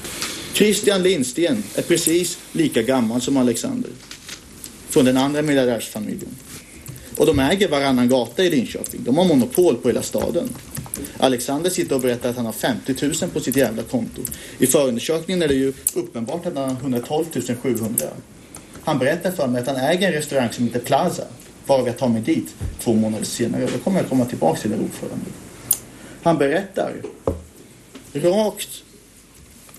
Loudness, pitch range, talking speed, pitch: -20 LUFS, 125-165 Hz, 160 wpm, 135 Hz